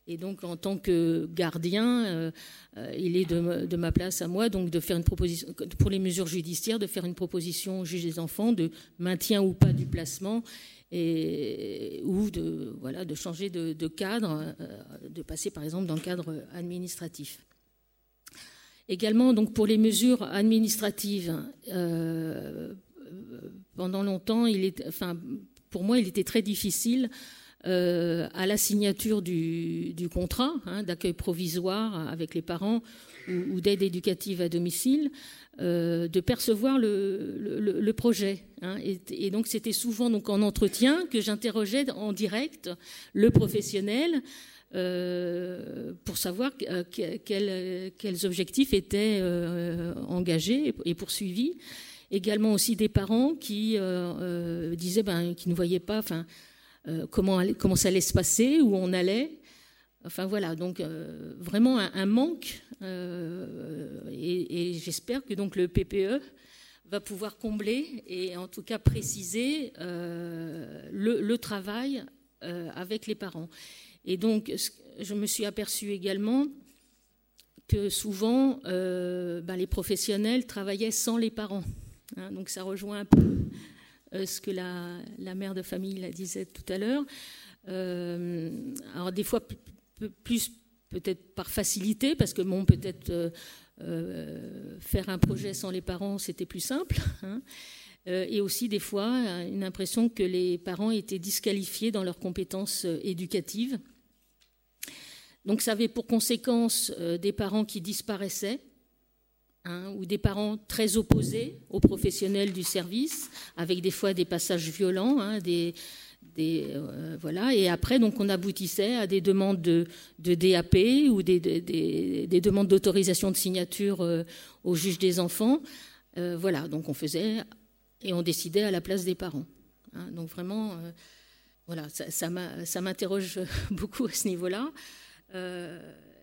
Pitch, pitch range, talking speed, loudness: 195 Hz, 175-220 Hz, 155 wpm, -29 LUFS